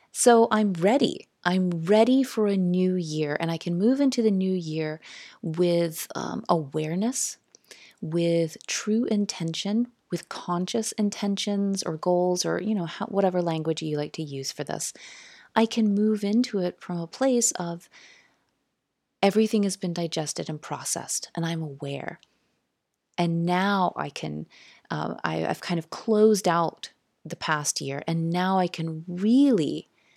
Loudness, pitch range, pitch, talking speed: -26 LUFS, 165-215 Hz, 180 Hz, 155 wpm